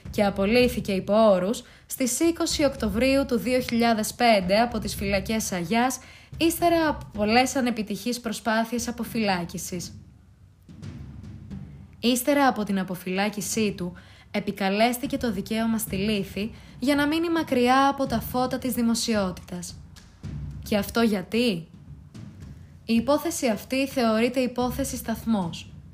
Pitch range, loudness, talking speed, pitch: 195-250 Hz, -25 LUFS, 105 wpm, 225 Hz